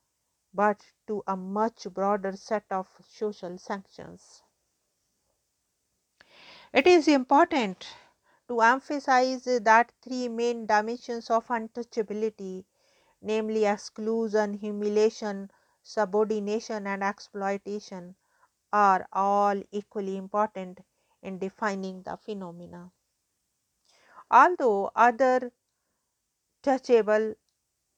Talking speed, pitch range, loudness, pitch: 80 wpm, 195-230 Hz, -26 LUFS, 210 Hz